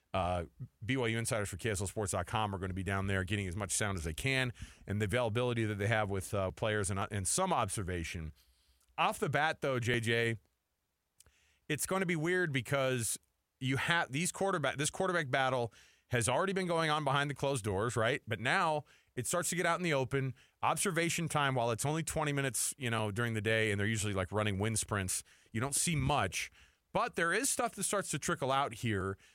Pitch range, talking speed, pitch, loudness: 100-145 Hz, 210 wpm, 120 Hz, -34 LUFS